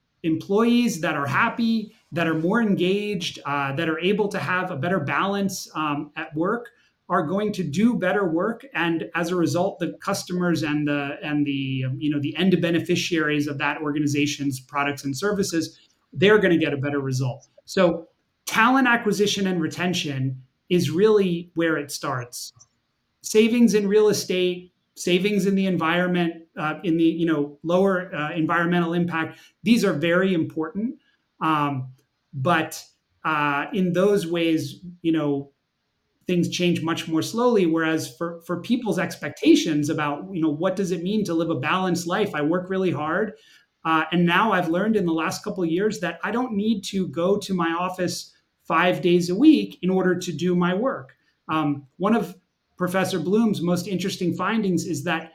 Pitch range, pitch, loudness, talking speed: 155-195 Hz, 175 Hz, -23 LUFS, 170 wpm